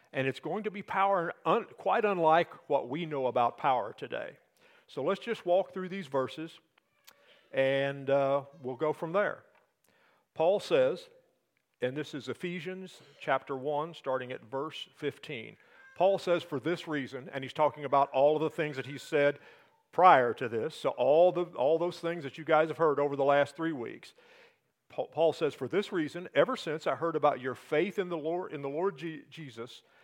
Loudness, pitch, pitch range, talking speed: -31 LUFS, 160 Hz, 140-185 Hz, 190 wpm